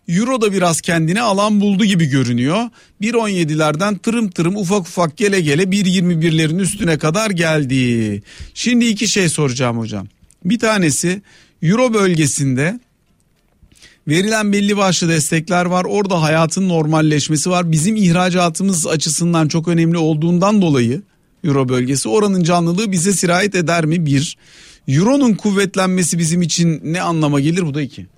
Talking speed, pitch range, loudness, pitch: 135 wpm, 155-200 Hz, -15 LUFS, 175 Hz